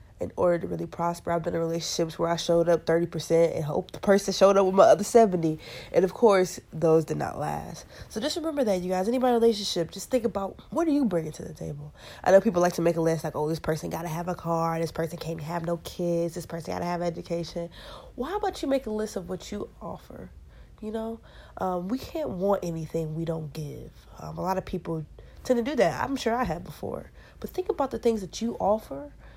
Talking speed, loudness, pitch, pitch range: 250 wpm, -27 LUFS, 175 Hz, 165-220 Hz